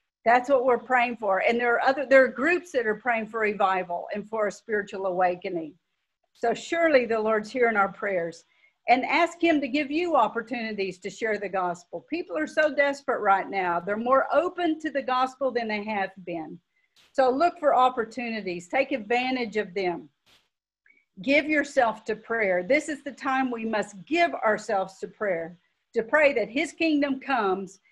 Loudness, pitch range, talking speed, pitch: -25 LUFS, 200-275 Hz, 180 wpm, 230 Hz